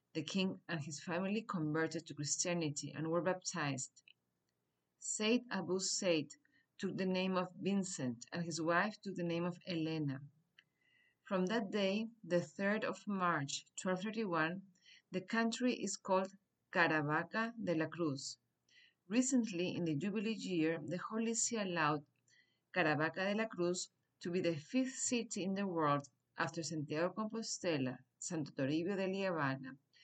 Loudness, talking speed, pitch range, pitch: -38 LUFS, 140 wpm, 155-195 Hz, 175 Hz